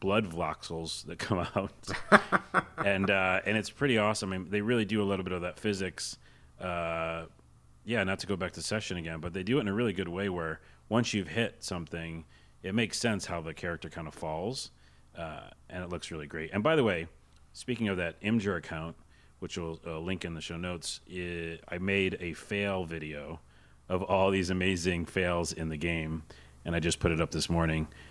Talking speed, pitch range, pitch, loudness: 210 wpm, 80-95 Hz, 85 Hz, -32 LUFS